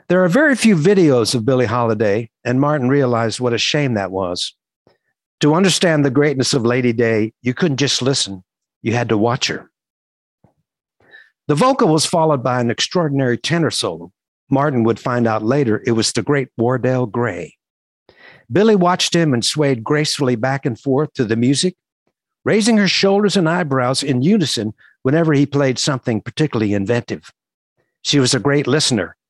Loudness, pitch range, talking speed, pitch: -16 LUFS, 120-155 Hz, 170 wpm, 135 Hz